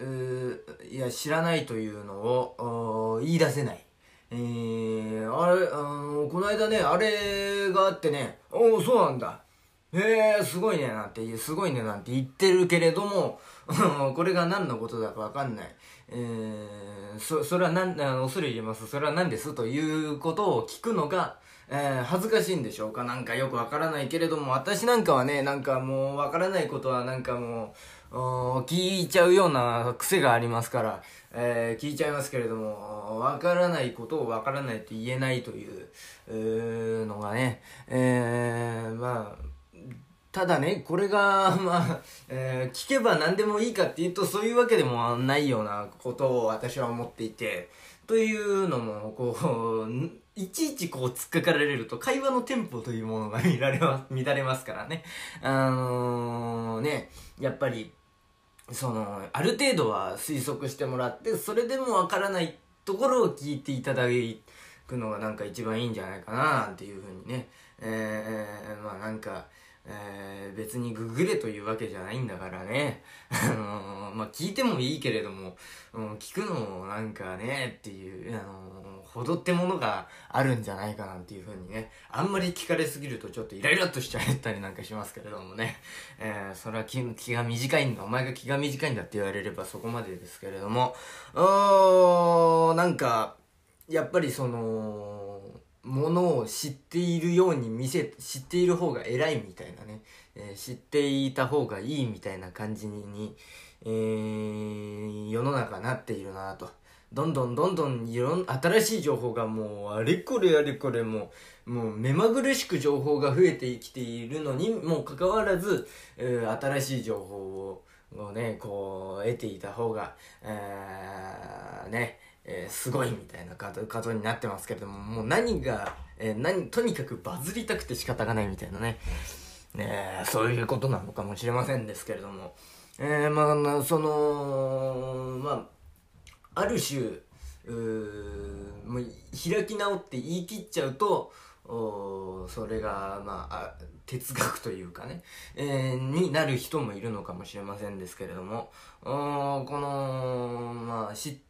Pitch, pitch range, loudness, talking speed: 125 Hz, 110-155 Hz, -29 LUFS, 320 characters per minute